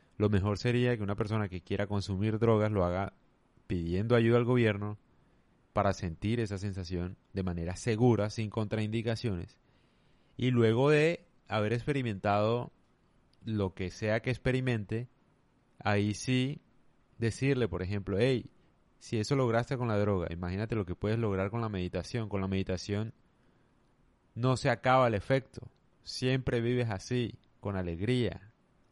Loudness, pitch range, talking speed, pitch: -32 LUFS, 100-120 Hz, 140 wpm, 110 Hz